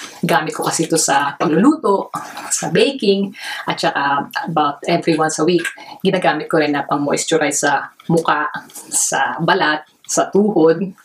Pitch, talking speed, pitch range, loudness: 165 Hz, 145 wpm, 155-190 Hz, -17 LUFS